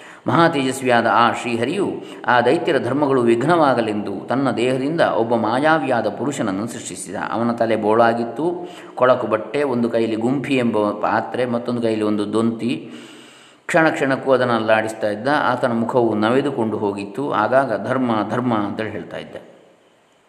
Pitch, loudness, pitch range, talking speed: 115 Hz, -19 LUFS, 110-130 Hz, 120 wpm